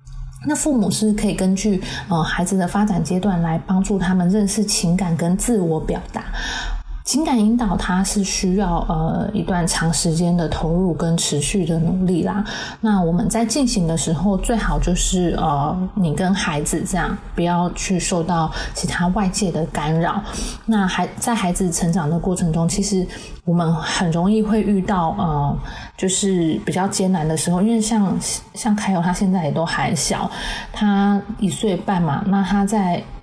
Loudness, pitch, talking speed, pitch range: -19 LUFS, 185 Hz, 250 characters per minute, 170-205 Hz